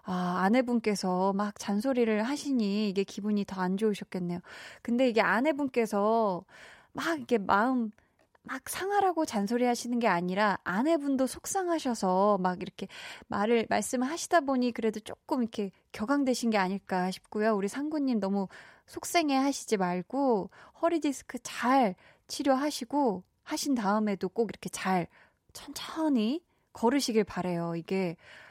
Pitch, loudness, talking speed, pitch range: 225 Hz, -30 LUFS, 310 characters per minute, 195-265 Hz